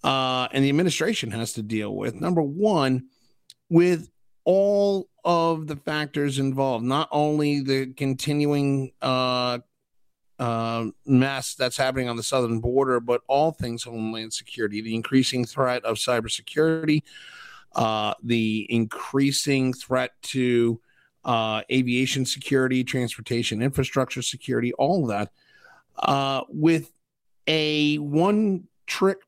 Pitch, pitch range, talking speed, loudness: 130 Hz, 120-150 Hz, 120 wpm, -24 LUFS